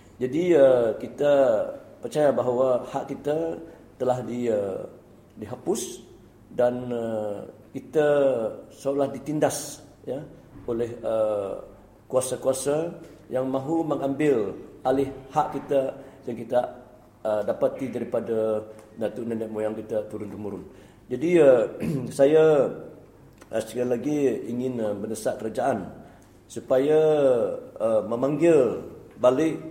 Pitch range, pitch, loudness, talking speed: 115-150 Hz, 130 Hz, -25 LUFS, 100 wpm